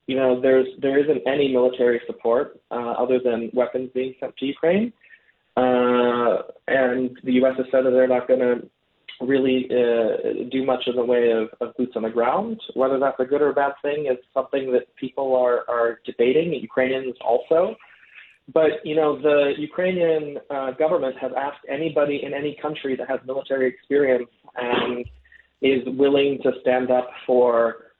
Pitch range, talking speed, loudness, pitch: 125-140 Hz, 175 wpm, -22 LUFS, 130 Hz